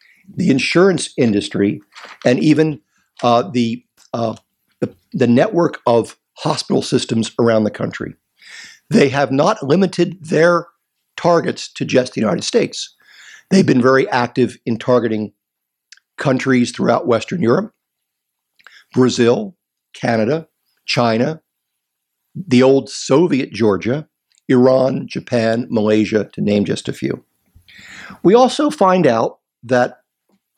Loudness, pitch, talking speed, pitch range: -16 LUFS, 125 Hz, 115 wpm, 115-165 Hz